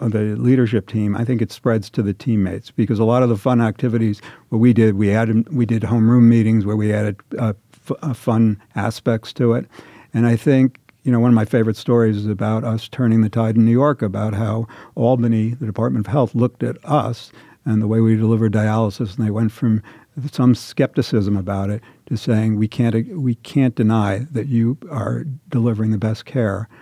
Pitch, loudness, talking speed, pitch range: 115 Hz, -18 LUFS, 210 wpm, 110-125 Hz